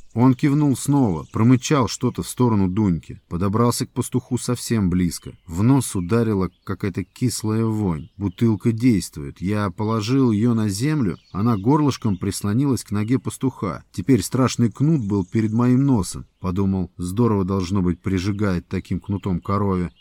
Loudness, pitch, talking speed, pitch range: -21 LUFS, 110 Hz, 140 wpm, 95-125 Hz